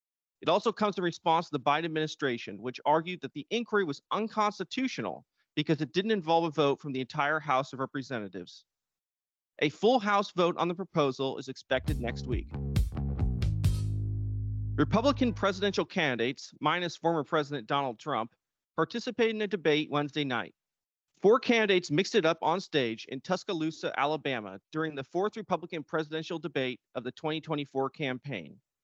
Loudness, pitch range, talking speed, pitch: -31 LUFS, 130-180 Hz, 150 wpm, 150 Hz